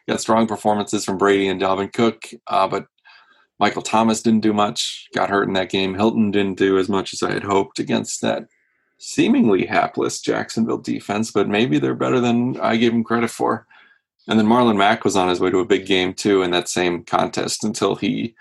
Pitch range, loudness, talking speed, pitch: 95-110 Hz, -19 LUFS, 210 wpm, 100 Hz